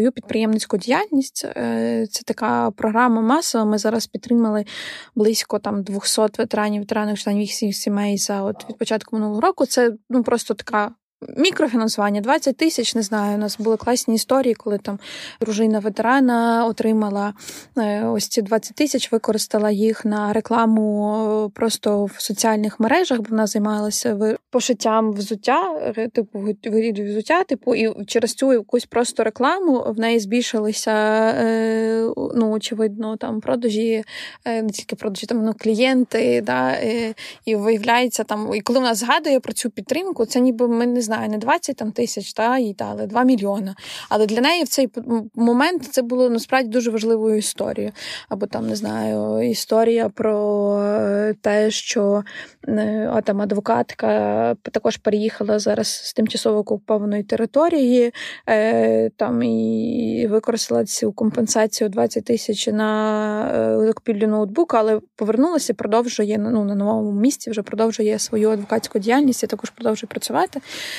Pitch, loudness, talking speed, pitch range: 220 Hz, -20 LUFS, 135 wpm, 210-240 Hz